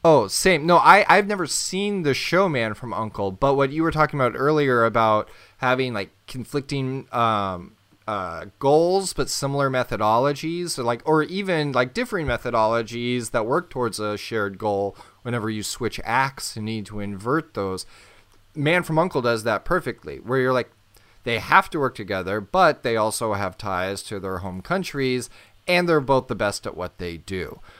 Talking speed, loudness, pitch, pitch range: 180 wpm, -22 LUFS, 125 Hz, 105-150 Hz